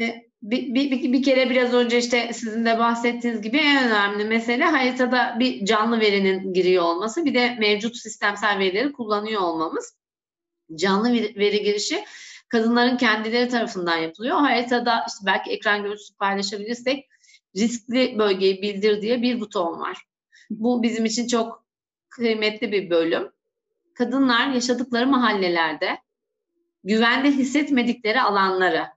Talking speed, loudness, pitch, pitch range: 125 wpm, -21 LUFS, 235 Hz, 210-255 Hz